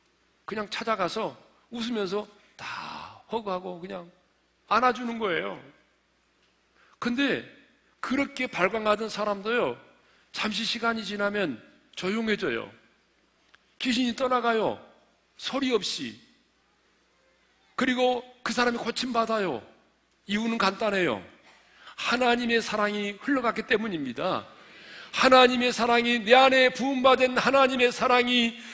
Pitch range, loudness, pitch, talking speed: 210-250 Hz, -26 LUFS, 235 Hz, 245 characters per minute